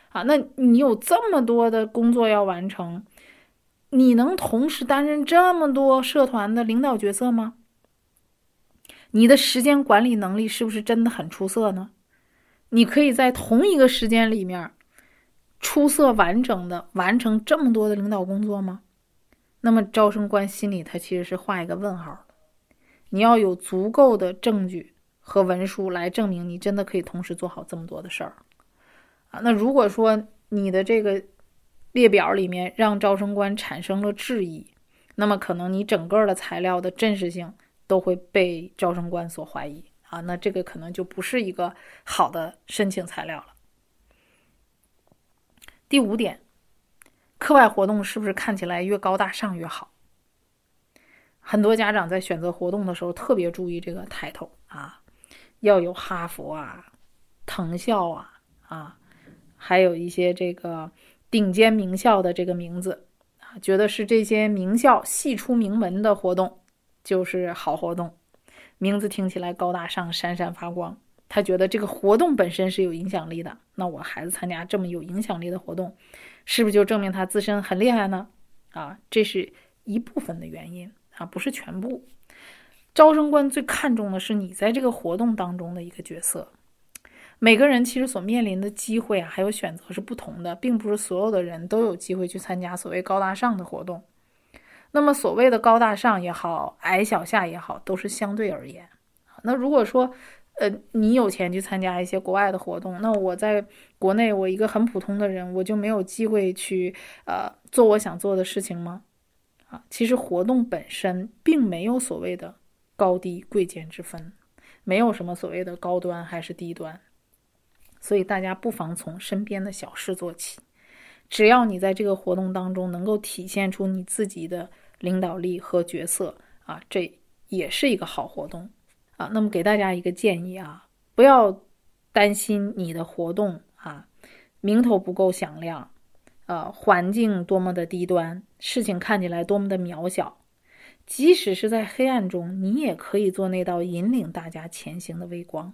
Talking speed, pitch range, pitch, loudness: 250 characters per minute, 180-225 Hz, 200 Hz, -23 LUFS